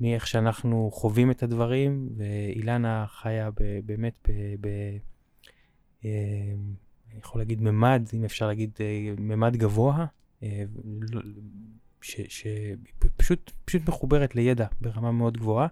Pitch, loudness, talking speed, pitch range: 110 Hz, -28 LUFS, 110 wpm, 105-120 Hz